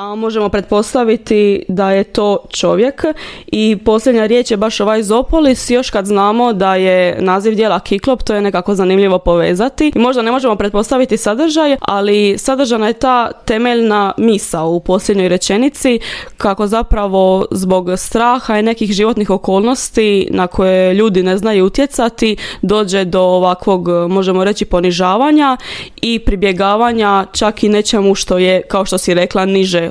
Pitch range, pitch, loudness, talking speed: 190-230 Hz, 210 Hz, -12 LUFS, 150 wpm